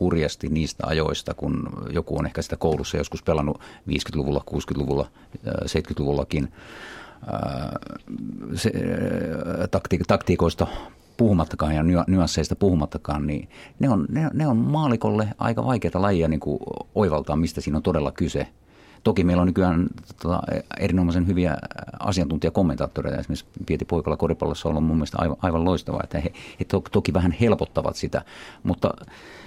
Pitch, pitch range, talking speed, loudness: 85 Hz, 75-95 Hz, 135 wpm, -24 LUFS